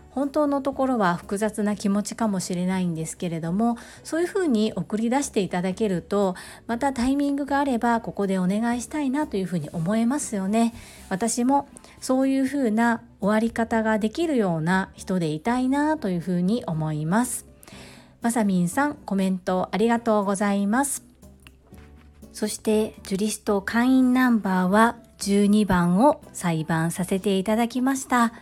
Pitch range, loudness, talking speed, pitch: 185-245 Hz, -24 LUFS, 340 characters per minute, 215 Hz